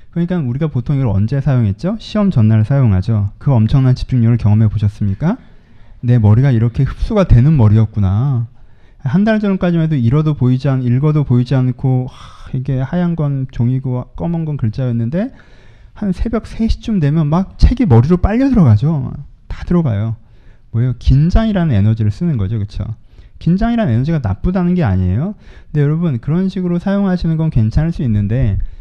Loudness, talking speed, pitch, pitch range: -15 LUFS, 380 characters per minute, 130 Hz, 115-165 Hz